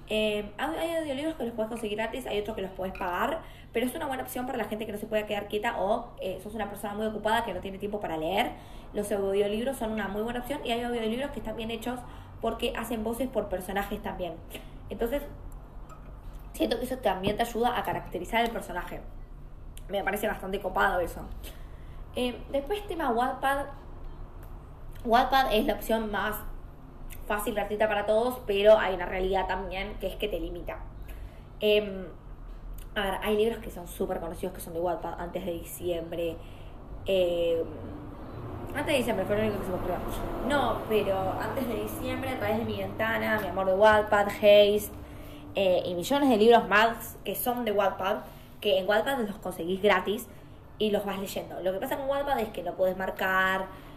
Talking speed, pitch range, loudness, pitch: 190 wpm, 190-230 Hz, -29 LUFS, 210 Hz